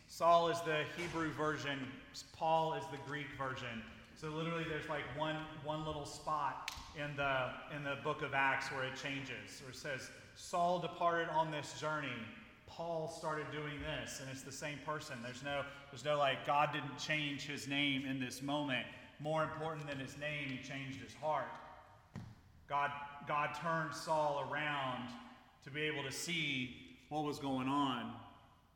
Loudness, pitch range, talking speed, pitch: -39 LUFS, 135-155 Hz, 170 wpm, 145 Hz